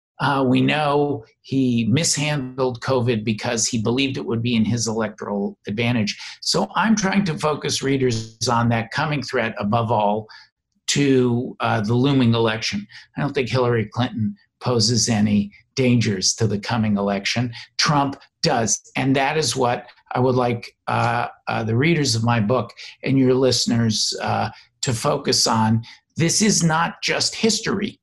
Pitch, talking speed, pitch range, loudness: 120 Hz, 155 wpm, 115-135 Hz, -20 LUFS